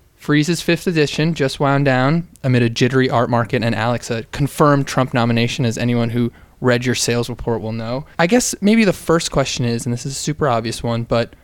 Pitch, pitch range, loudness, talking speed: 130 Hz, 120-150 Hz, -18 LUFS, 215 wpm